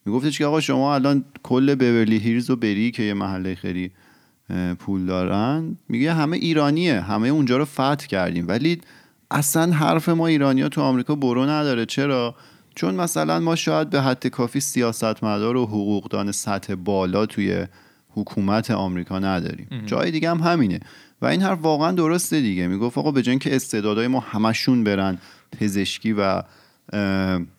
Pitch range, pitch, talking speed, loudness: 100-140 Hz, 115 Hz, 155 wpm, -21 LUFS